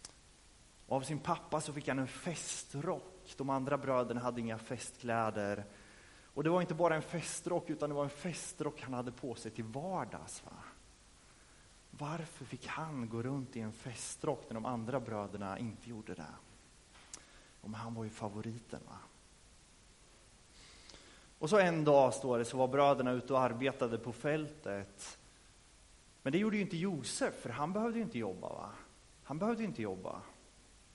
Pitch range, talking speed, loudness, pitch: 115-155 Hz, 170 wpm, -37 LUFS, 130 Hz